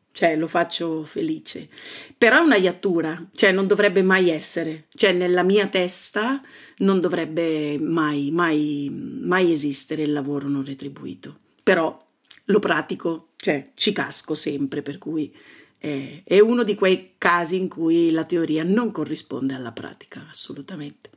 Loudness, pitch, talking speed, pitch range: -21 LUFS, 170 Hz, 145 wpm, 150-190 Hz